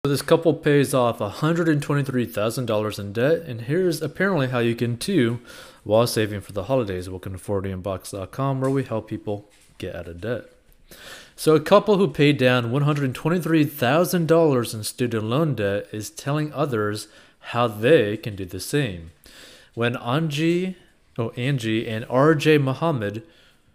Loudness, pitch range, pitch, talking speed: -22 LUFS, 110-155 Hz, 125 Hz, 150 wpm